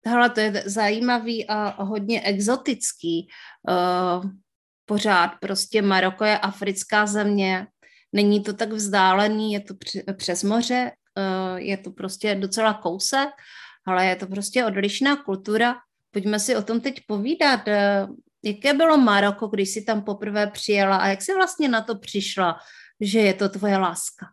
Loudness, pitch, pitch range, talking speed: -22 LUFS, 205 Hz, 195-225 Hz, 145 wpm